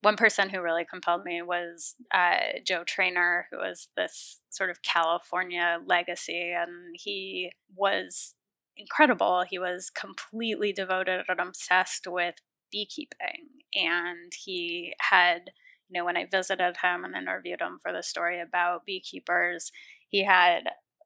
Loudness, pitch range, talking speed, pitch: -28 LUFS, 175-210 Hz, 135 wpm, 185 Hz